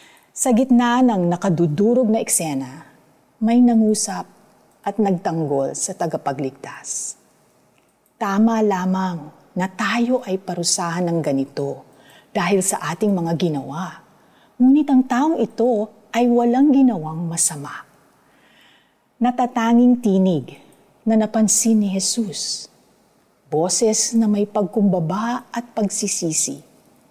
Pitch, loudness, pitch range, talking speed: 205 Hz, -19 LUFS, 170-235 Hz, 100 wpm